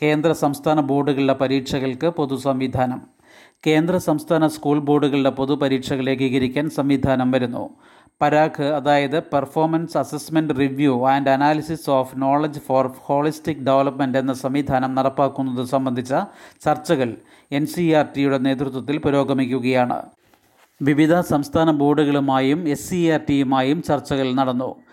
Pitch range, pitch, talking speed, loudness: 135-150 Hz, 140 Hz, 115 wpm, -20 LUFS